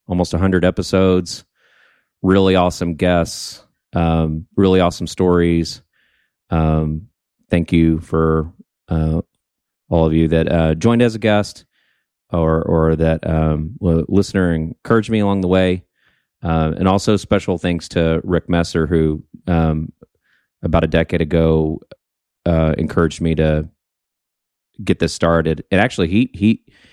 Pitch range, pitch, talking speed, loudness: 80-90 Hz, 85 Hz, 130 wpm, -17 LUFS